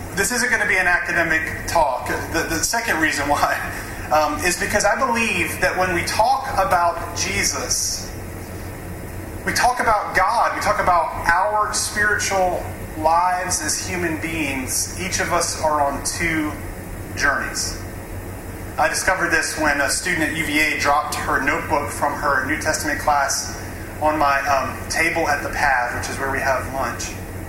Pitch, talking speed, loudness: 110 Hz, 160 wpm, -20 LUFS